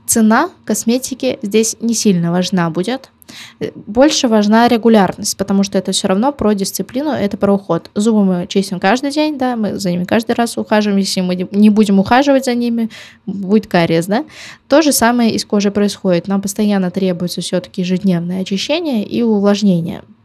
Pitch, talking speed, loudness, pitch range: 205 Hz, 165 wpm, -14 LUFS, 190-230 Hz